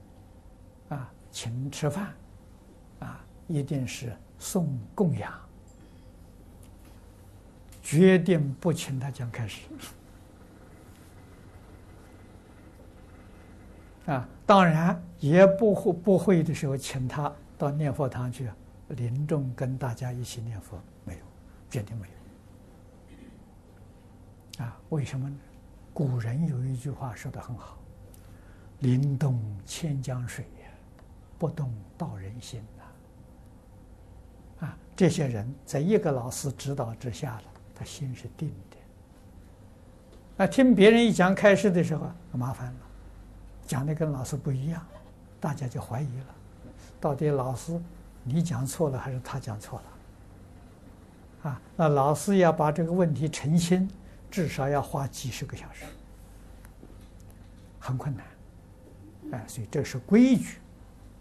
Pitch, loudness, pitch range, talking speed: 120 Hz, -27 LUFS, 95-145 Hz, 165 characters per minute